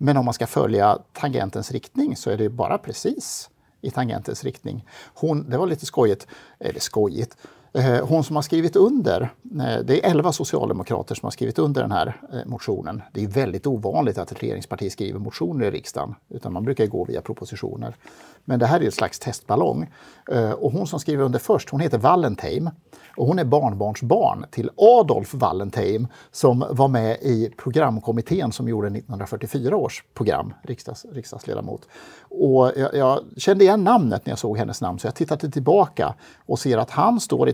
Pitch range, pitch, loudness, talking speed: 115-155 Hz, 130 Hz, -22 LUFS, 175 wpm